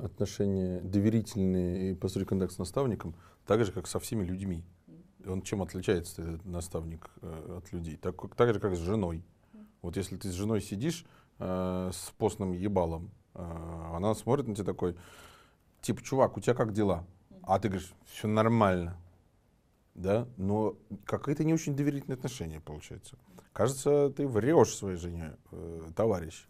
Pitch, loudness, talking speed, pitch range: 95 Hz, -32 LUFS, 155 wpm, 90-110 Hz